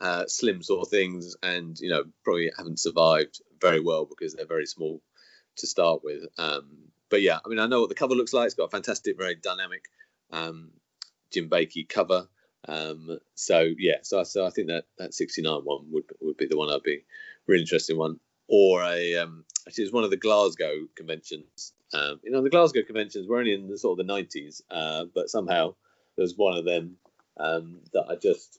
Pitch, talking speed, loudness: 95 Hz, 210 wpm, -27 LUFS